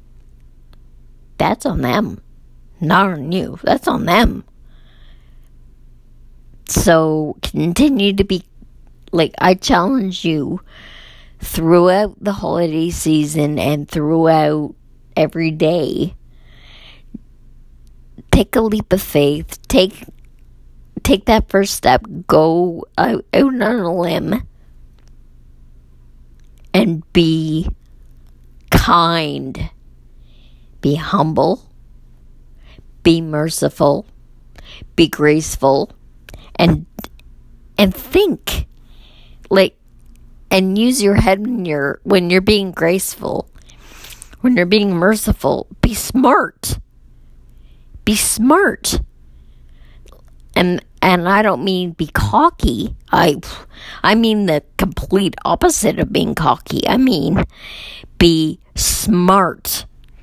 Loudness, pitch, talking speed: -15 LUFS, 160 Hz, 90 wpm